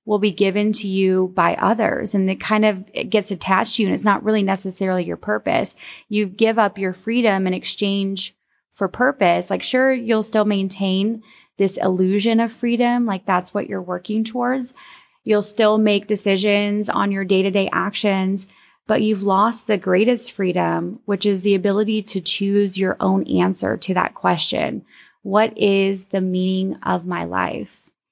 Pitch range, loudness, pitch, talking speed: 190-215 Hz, -19 LUFS, 200 Hz, 175 wpm